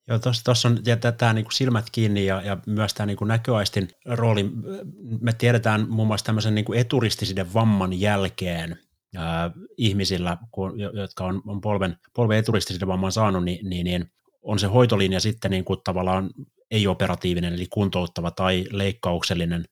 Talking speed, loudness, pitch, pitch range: 150 wpm, -24 LUFS, 100 Hz, 95-110 Hz